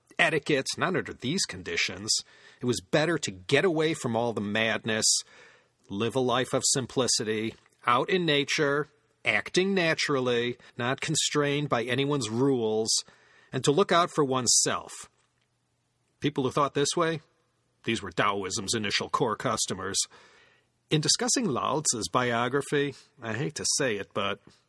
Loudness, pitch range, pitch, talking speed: -27 LUFS, 115-150 Hz, 135 Hz, 140 wpm